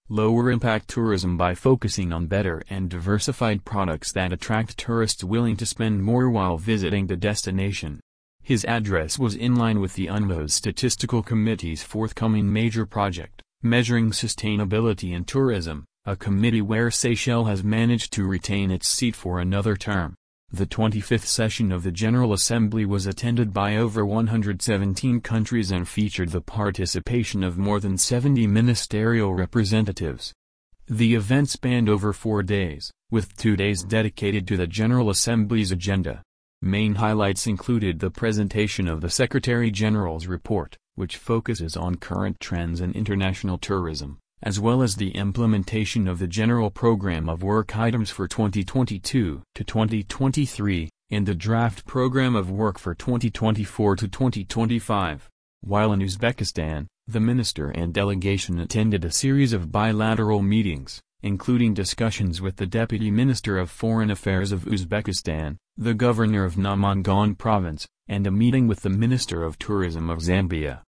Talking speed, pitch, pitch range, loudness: 140 wpm, 105 Hz, 95-115 Hz, -23 LUFS